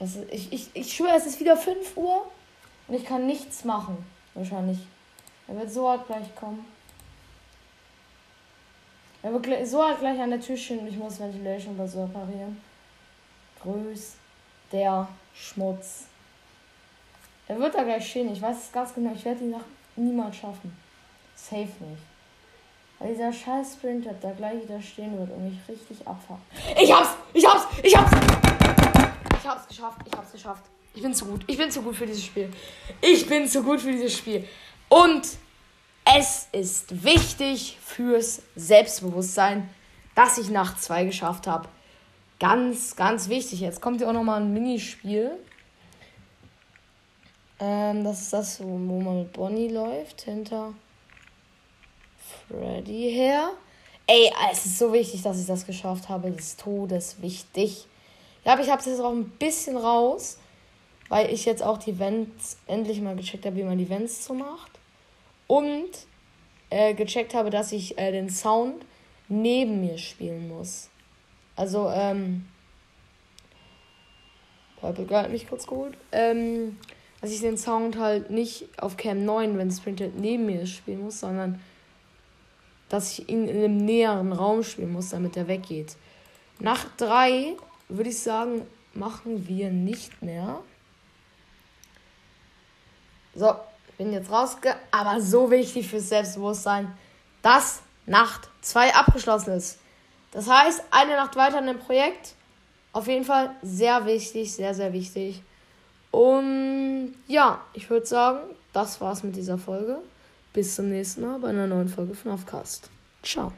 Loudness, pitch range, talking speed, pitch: -24 LUFS, 195-245 Hz, 150 wpm, 215 Hz